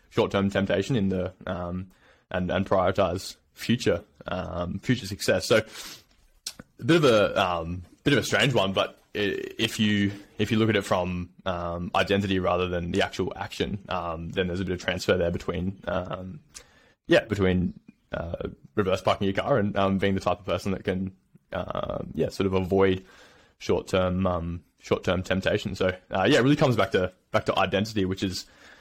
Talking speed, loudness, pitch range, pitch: 180 wpm, -26 LUFS, 90-100 Hz, 95 Hz